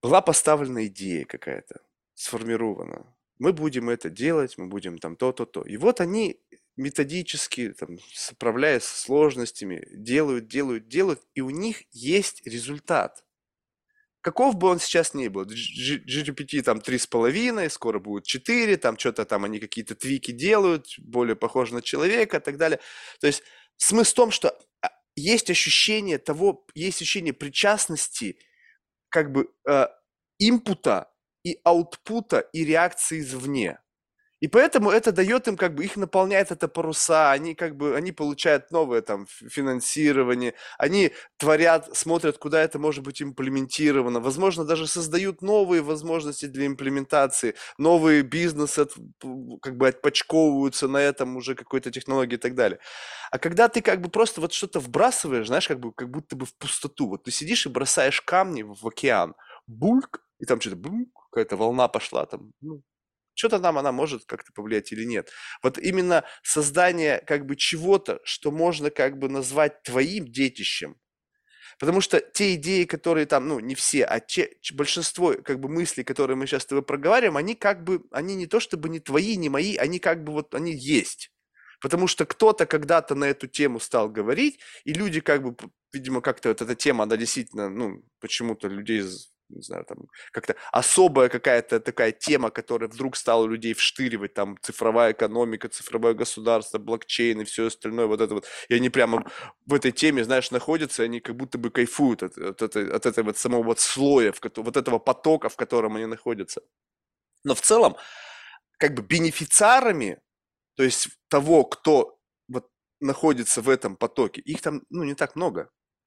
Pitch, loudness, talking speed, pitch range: 150 Hz, -24 LUFS, 160 wpm, 125-180 Hz